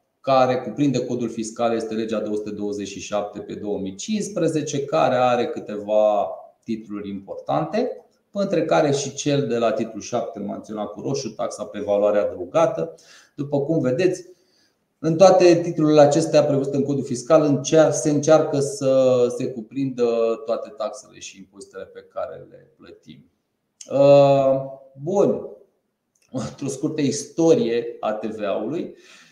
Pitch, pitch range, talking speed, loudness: 135 Hz, 110-155 Hz, 120 wpm, -21 LUFS